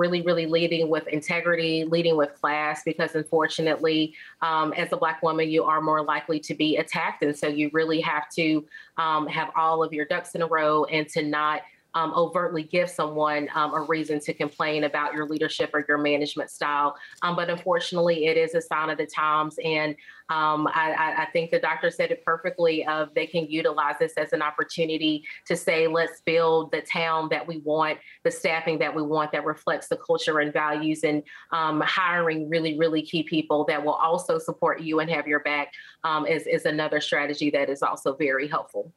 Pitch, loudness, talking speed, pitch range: 160 Hz, -25 LUFS, 200 wpm, 150-165 Hz